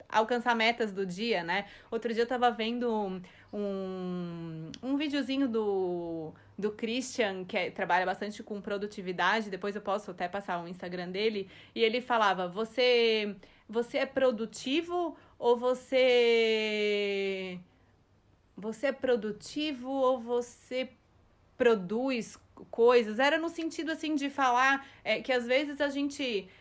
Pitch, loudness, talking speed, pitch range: 225 Hz, -30 LUFS, 135 wpm, 195-255 Hz